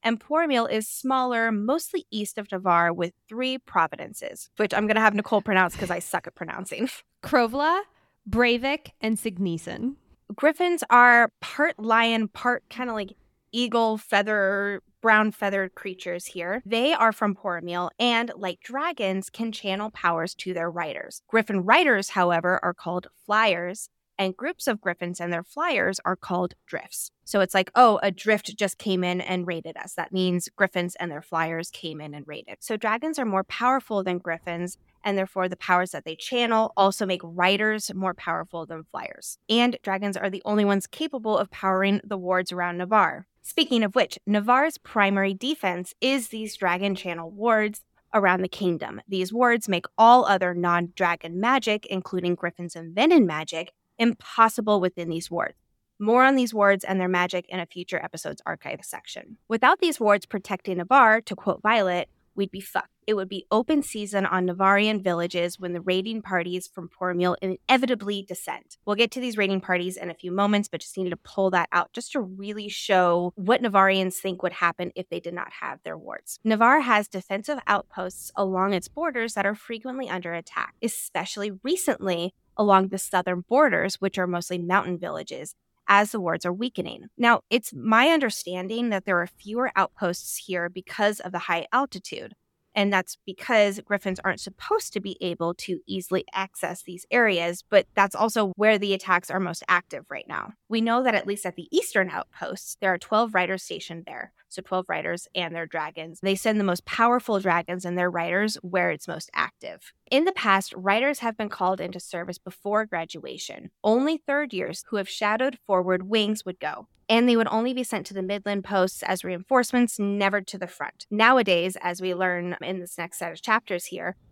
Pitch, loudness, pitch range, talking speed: 195 Hz, -24 LUFS, 180-225 Hz, 185 wpm